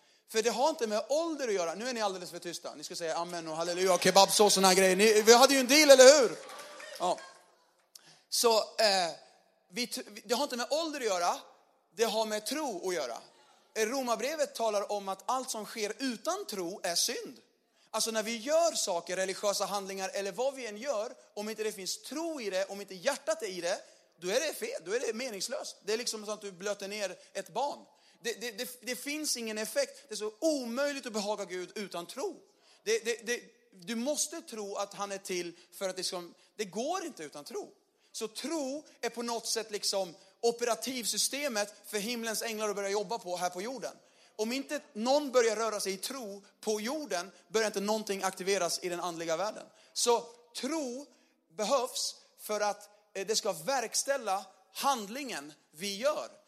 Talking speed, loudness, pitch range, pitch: 200 wpm, -31 LUFS, 195-270 Hz, 220 Hz